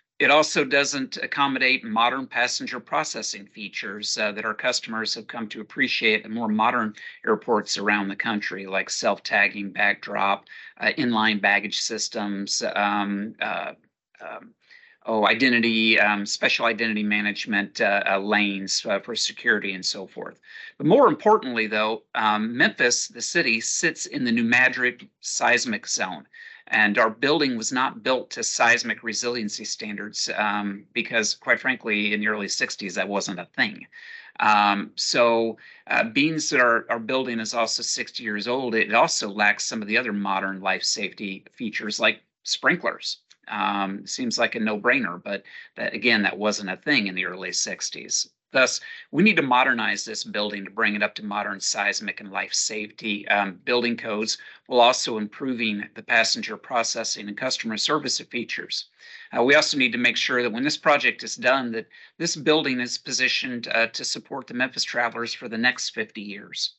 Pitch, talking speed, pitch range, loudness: 110 Hz, 170 wpm, 105-125 Hz, -23 LUFS